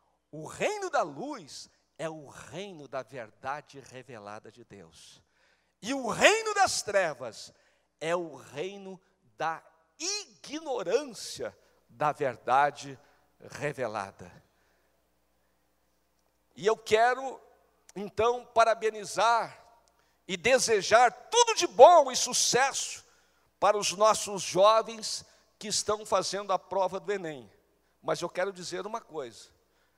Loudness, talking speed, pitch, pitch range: -27 LUFS, 110 wpm, 200 Hz, 145-230 Hz